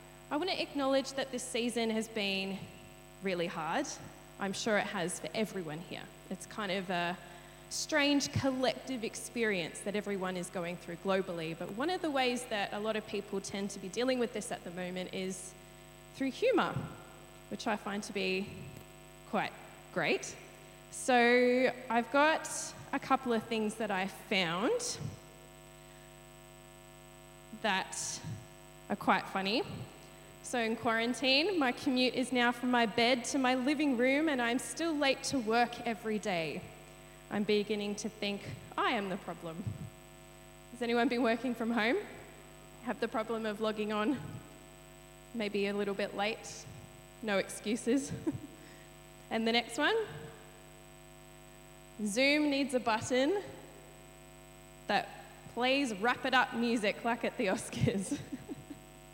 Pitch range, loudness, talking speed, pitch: 195-255 Hz, -33 LUFS, 145 wpm, 225 Hz